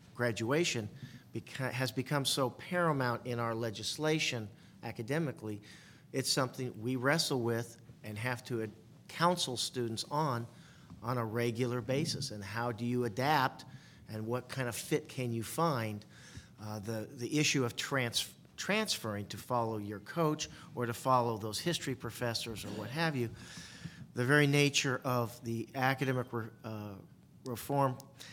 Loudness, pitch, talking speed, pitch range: -34 LUFS, 125 Hz, 145 wpm, 115-140 Hz